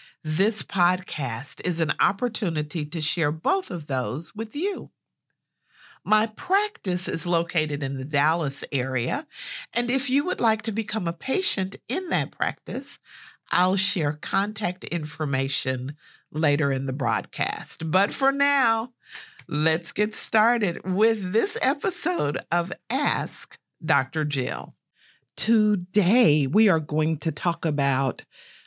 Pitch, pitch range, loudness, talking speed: 175 Hz, 150-215 Hz, -25 LUFS, 125 wpm